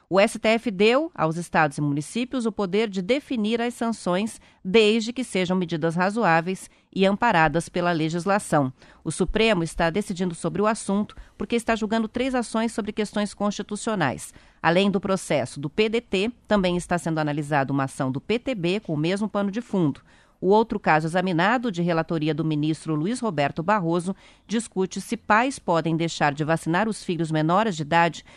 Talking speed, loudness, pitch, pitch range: 165 wpm, -24 LUFS, 190 Hz, 165-220 Hz